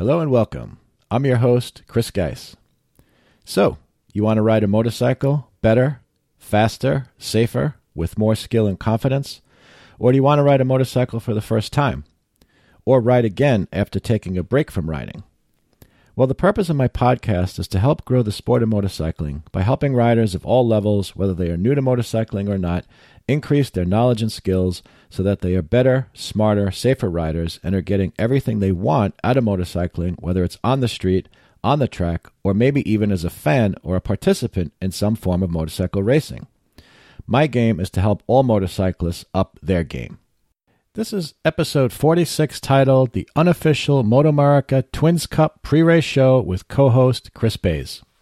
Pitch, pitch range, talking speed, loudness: 110 Hz, 95-130 Hz, 180 wpm, -19 LUFS